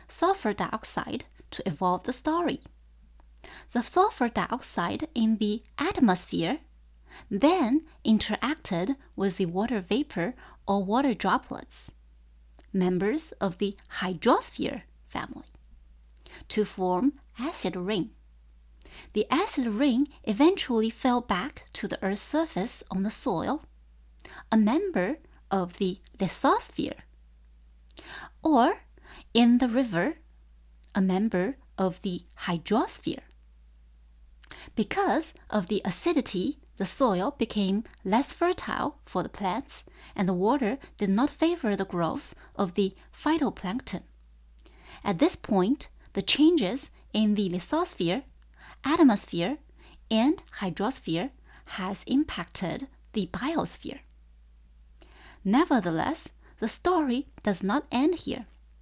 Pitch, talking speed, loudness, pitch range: 210 Hz, 105 wpm, -28 LUFS, 180-270 Hz